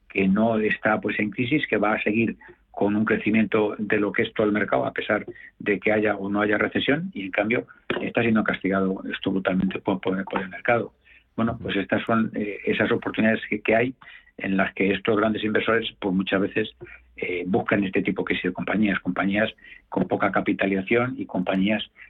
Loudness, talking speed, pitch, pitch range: -24 LUFS, 200 wpm, 105 Hz, 95-110 Hz